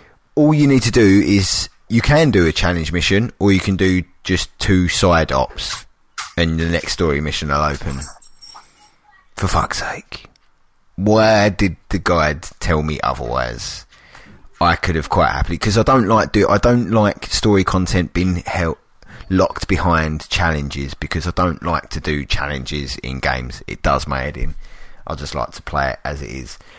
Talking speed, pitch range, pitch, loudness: 180 wpm, 75-100 Hz, 85 Hz, -17 LUFS